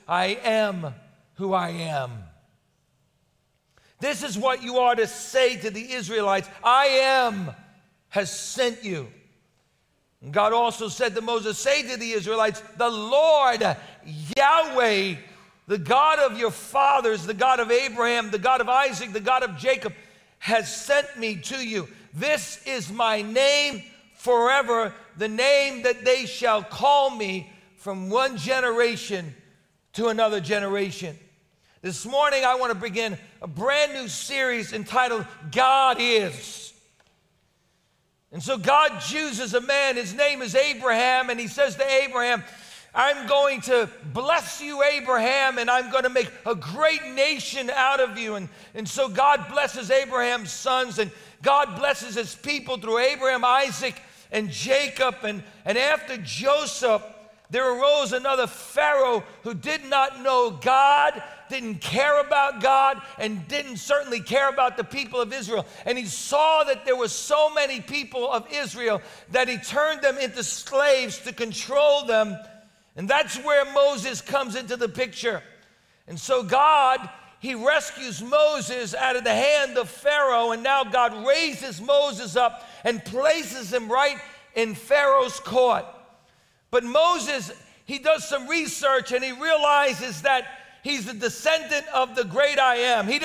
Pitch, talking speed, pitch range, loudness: 250 Hz, 150 wpm, 220-275 Hz, -23 LUFS